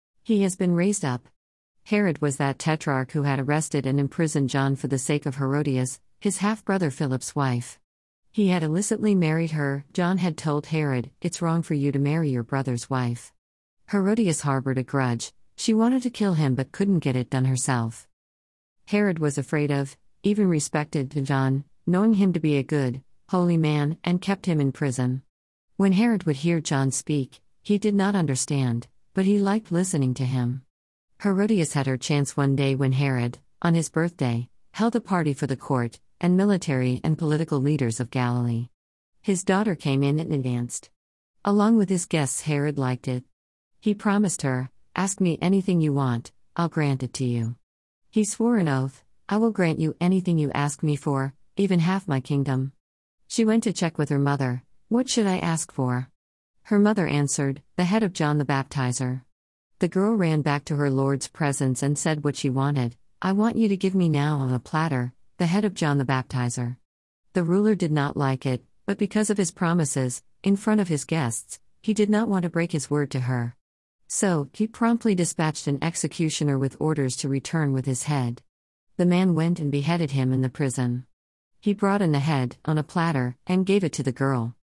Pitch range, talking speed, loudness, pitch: 130-180 Hz, 195 wpm, -24 LUFS, 145 Hz